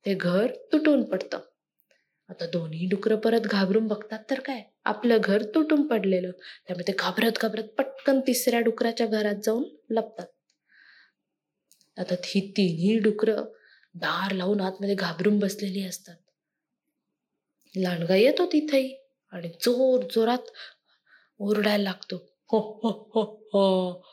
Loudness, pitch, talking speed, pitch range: -26 LUFS, 215 Hz, 125 wpm, 195-240 Hz